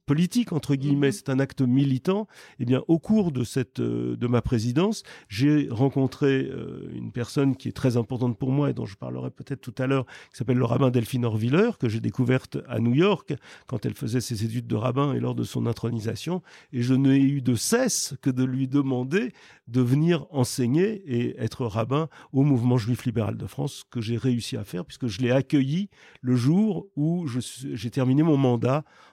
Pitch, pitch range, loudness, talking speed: 130 Hz, 120-145 Hz, -25 LUFS, 200 wpm